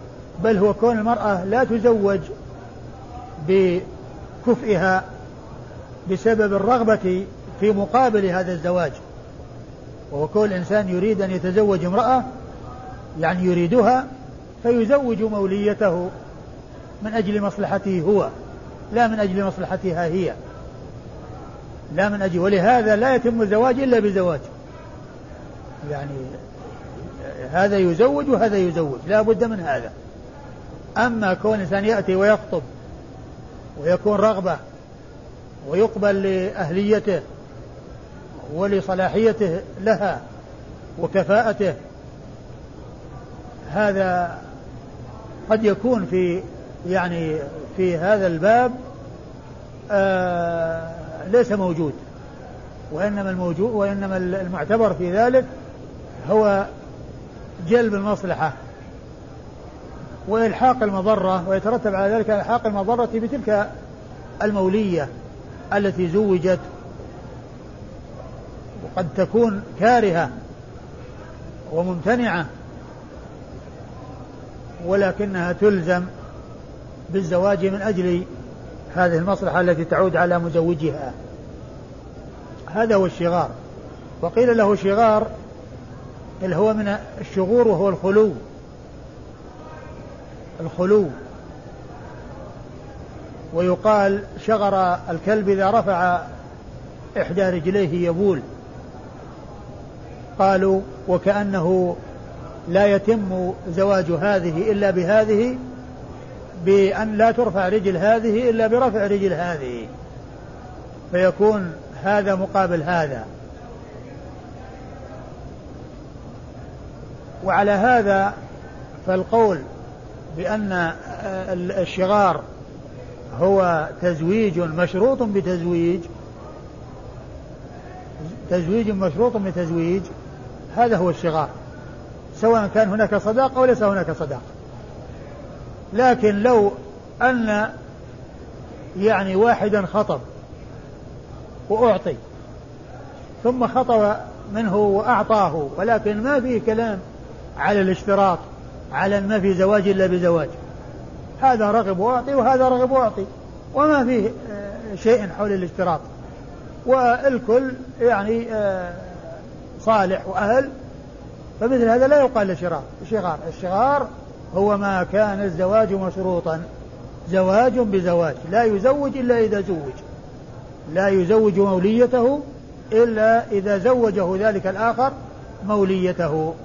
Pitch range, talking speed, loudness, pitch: 175-215 Hz, 80 wpm, -20 LUFS, 195 Hz